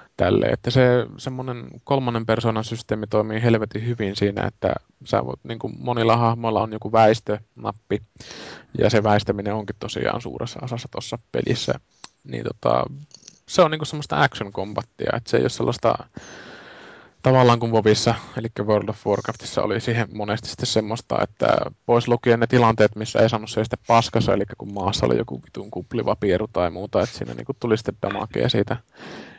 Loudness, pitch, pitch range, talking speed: -22 LUFS, 115 Hz, 105-120 Hz, 160 wpm